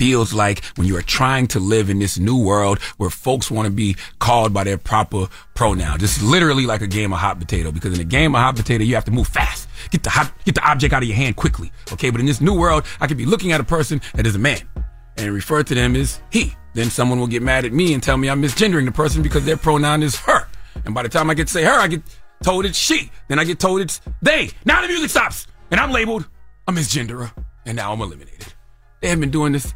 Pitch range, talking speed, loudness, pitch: 105-150 Hz, 270 wpm, -18 LUFS, 125 Hz